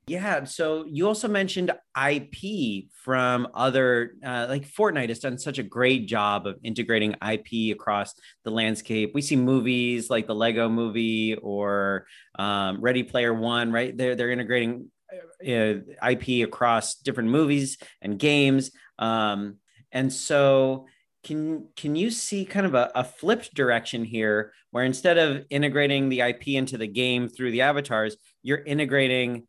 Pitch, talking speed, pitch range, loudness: 125 Hz, 155 wpm, 115-140 Hz, -25 LUFS